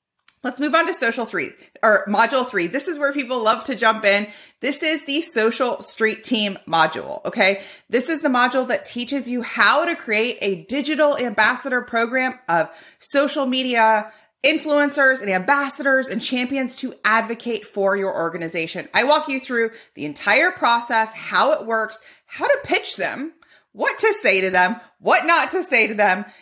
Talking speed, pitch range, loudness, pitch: 175 wpm, 215-285 Hz, -19 LUFS, 245 Hz